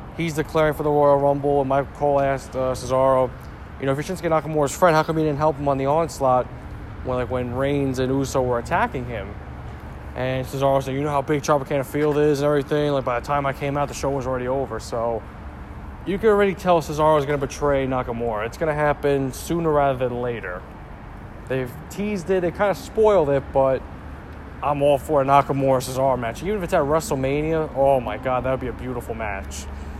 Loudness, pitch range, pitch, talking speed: -22 LUFS, 125-150 Hz, 140 Hz, 215 wpm